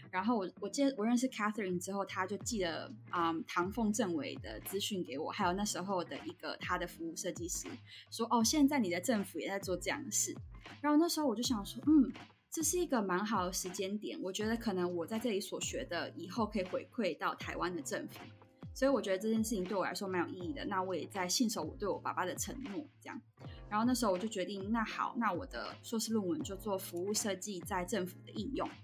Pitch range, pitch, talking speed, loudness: 180-235 Hz, 200 Hz, 360 characters per minute, -36 LUFS